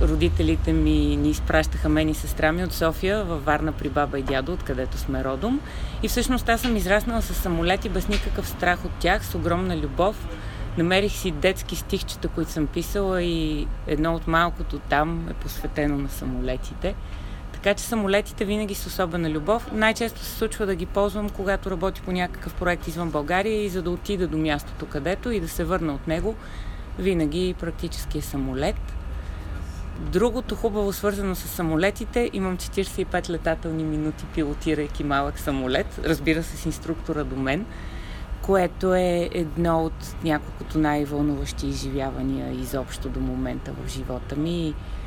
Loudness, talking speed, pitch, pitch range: -25 LUFS, 155 wpm, 165 Hz, 140-190 Hz